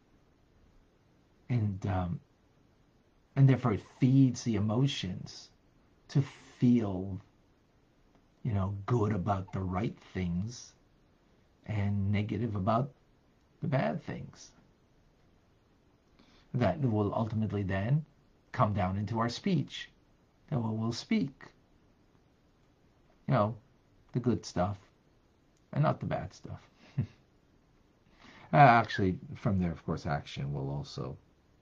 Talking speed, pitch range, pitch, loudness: 105 wpm, 95-125 Hz, 105 Hz, -32 LUFS